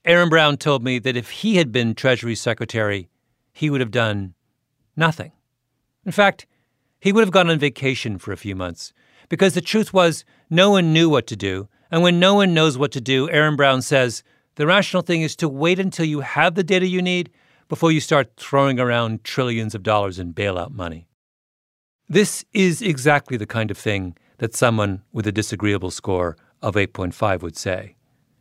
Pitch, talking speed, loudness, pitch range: 130 Hz, 190 wpm, -19 LUFS, 110-165 Hz